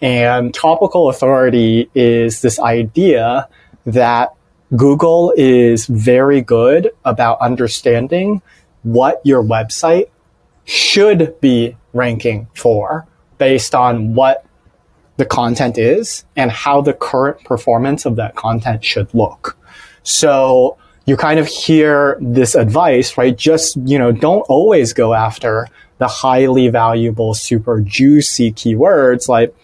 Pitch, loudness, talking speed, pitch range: 125 Hz, -12 LUFS, 115 wpm, 115-140 Hz